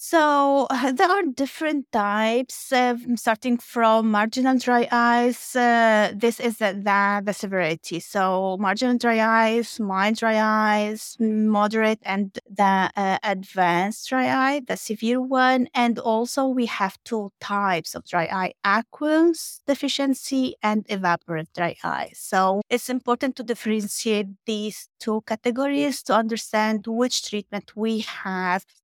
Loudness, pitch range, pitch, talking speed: -22 LUFS, 205-250 Hz, 225 Hz, 135 wpm